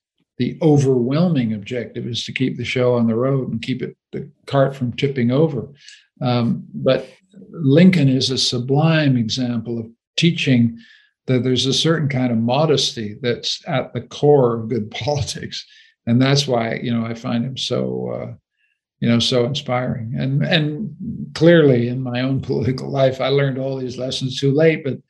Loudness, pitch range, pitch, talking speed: -19 LUFS, 120-140 Hz, 130 Hz, 170 wpm